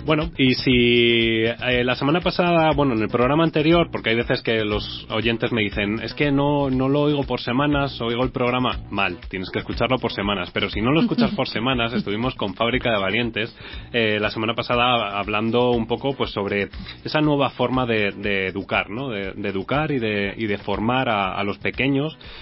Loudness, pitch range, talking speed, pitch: -21 LUFS, 105-135 Hz, 205 wpm, 120 Hz